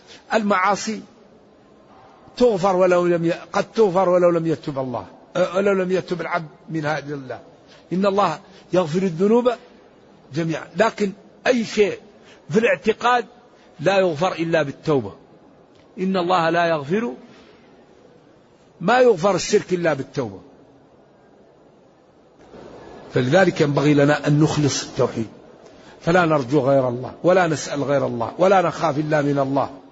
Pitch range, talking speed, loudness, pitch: 150-200 Hz, 120 wpm, -20 LUFS, 175 Hz